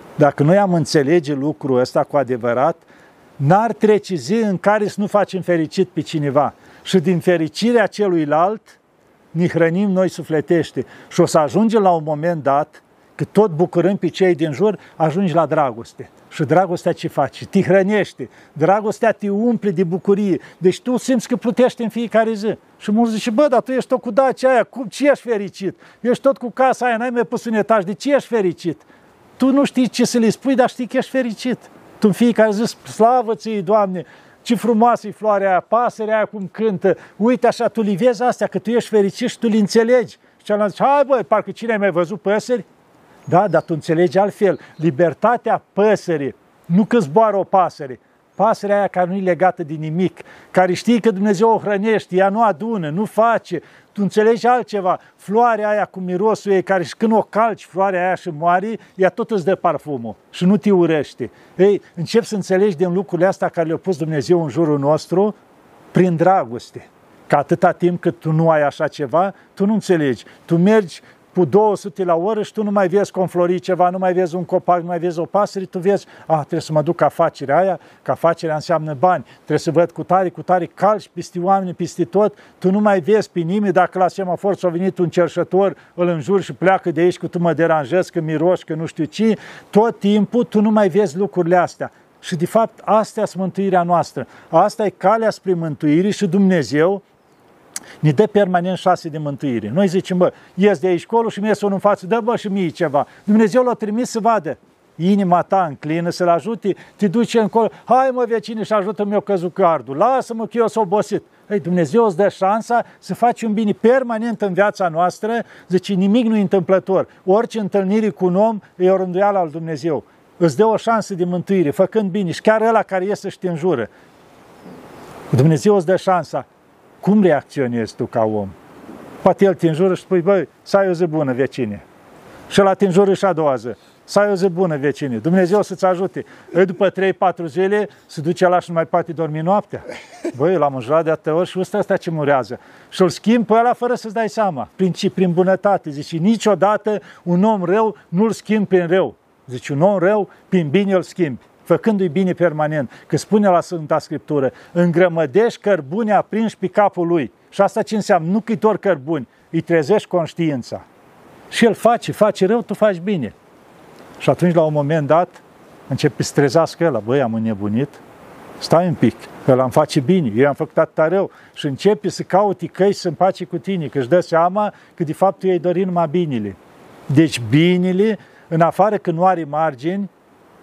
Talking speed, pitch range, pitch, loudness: 200 wpm, 170-210 Hz, 190 Hz, -17 LUFS